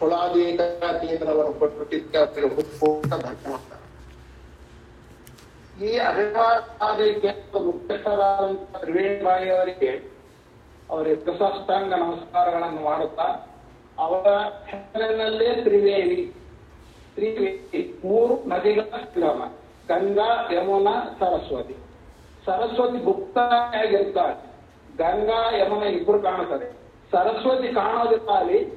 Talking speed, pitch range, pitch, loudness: 50 wpm, 175-235 Hz, 200 Hz, -23 LUFS